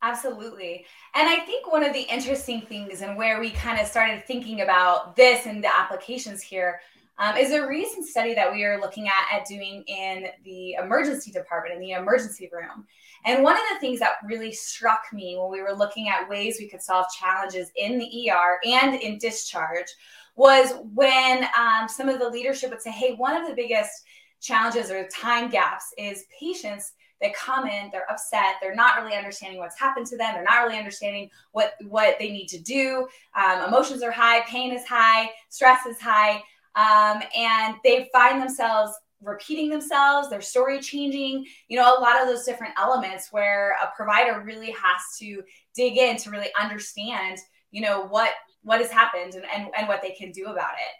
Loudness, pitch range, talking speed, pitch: -22 LUFS, 200-255 Hz, 195 wpm, 225 Hz